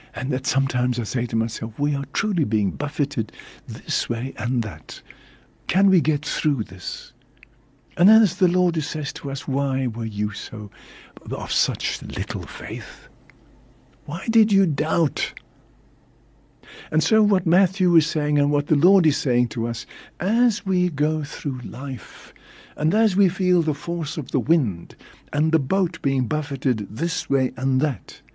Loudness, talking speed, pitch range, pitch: -22 LUFS, 165 wpm, 125-170 Hz, 145 Hz